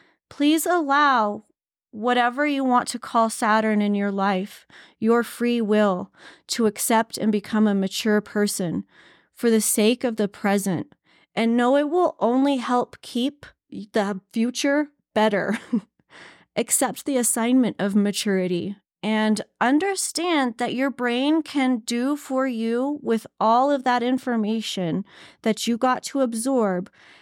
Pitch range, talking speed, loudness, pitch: 210-260 Hz, 135 wpm, -22 LUFS, 230 Hz